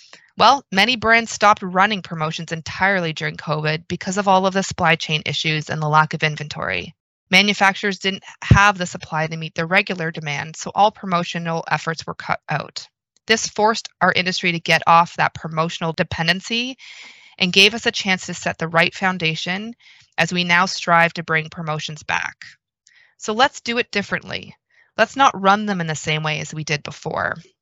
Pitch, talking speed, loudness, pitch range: 175 Hz, 185 wpm, -19 LUFS, 160-200 Hz